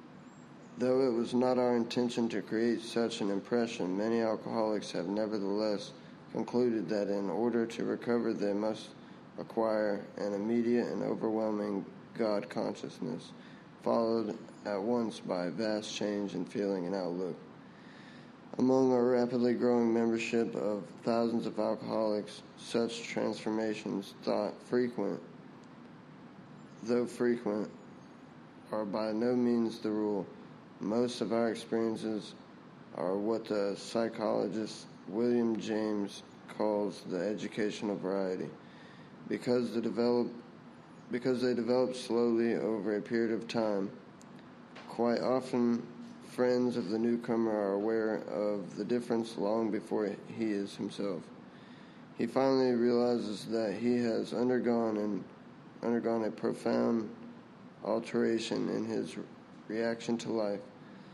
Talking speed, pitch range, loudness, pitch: 120 wpm, 105-120 Hz, -33 LUFS, 115 Hz